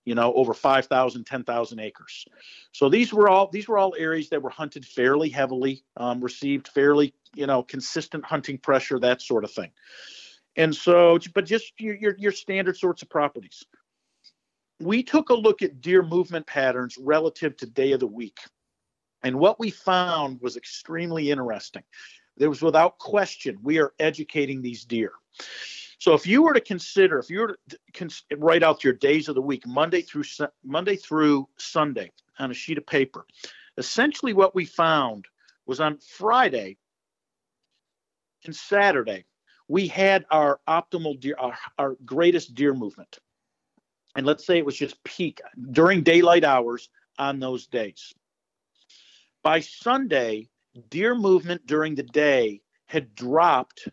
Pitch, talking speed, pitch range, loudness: 155 Hz, 155 wpm, 135-185 Hz, -23 LUFS